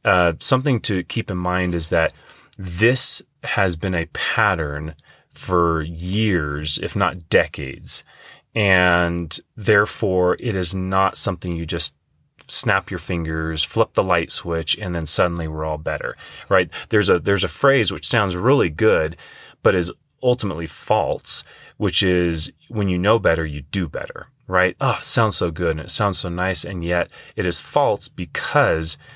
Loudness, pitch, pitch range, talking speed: -19 LUFS, 90 Hz, 85-95 Hz, 165 wpm